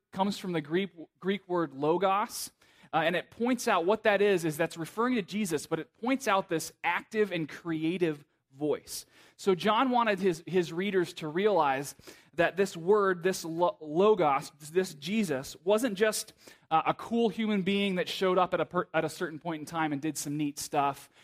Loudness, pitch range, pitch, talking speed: -30 LUFS, 160-205 Hz, 180 Hz, 195 wpm